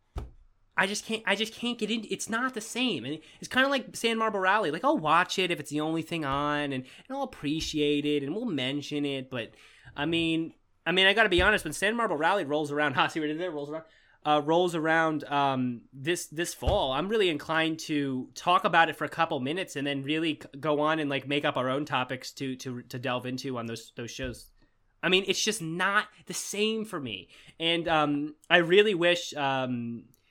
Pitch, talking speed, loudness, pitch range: 155 Hz, 225 wpm, -28 LUFS, 140-185 Hz